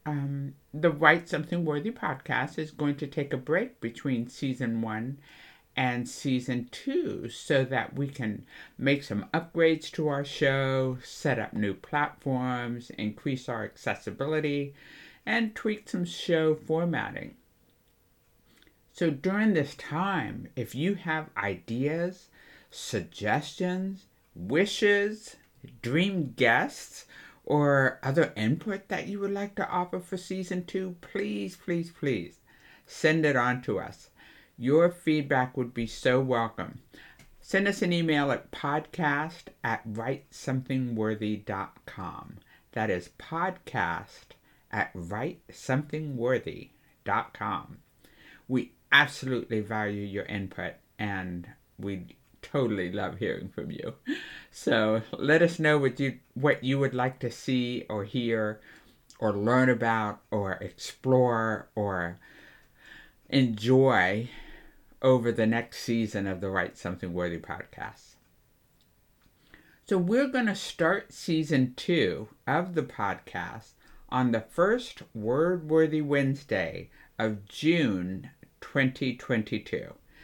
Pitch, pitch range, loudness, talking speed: 135 Hz, 115-160 Hz, -29 LUFS, 115 wpm